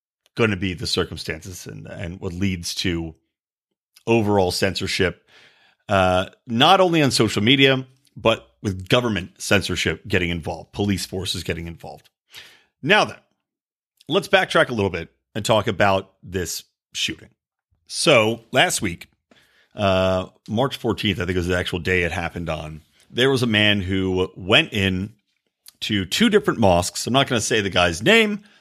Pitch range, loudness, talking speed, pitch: 90-120 Hz, -20 LUFS, 155 wpm, 100 Hz